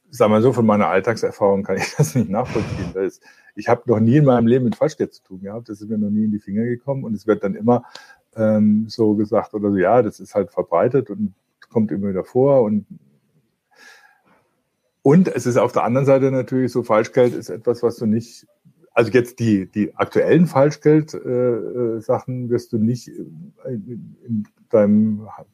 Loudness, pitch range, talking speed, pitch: -19 LUFS, 105-130 Hz, 195 wpm, 115 Hz